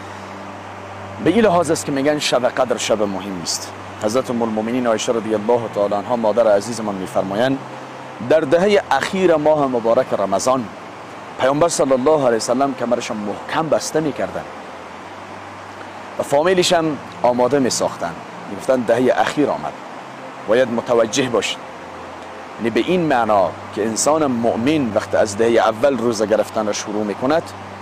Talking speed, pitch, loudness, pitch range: 145 wpm, 120 Hz, -18 LUFS, 105-140 Hz